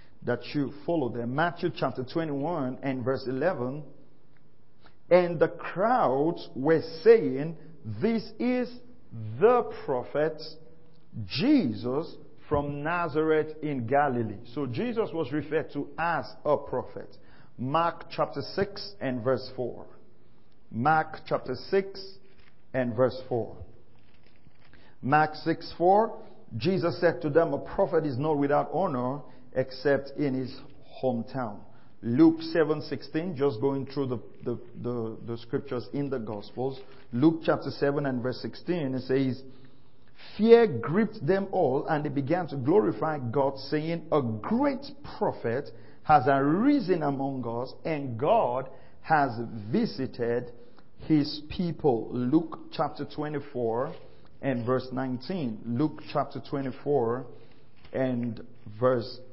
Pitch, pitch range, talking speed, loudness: 140 Hz, 125-160 Hz, 120 wpm, -28 LUFS